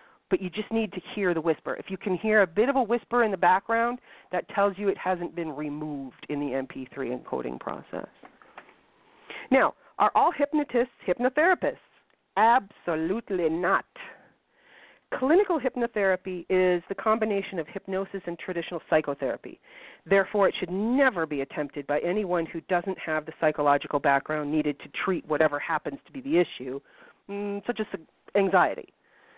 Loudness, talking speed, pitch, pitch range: -27 LUFS, 155 wpm, 185 Hz, 160-220 Hz